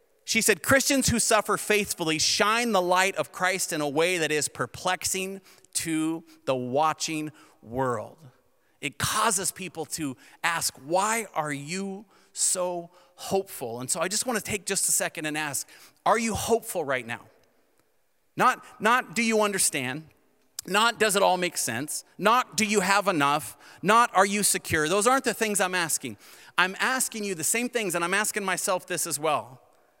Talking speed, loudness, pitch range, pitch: 175 wpm, -25 LUFS, 155-210 Hz, 185 Hz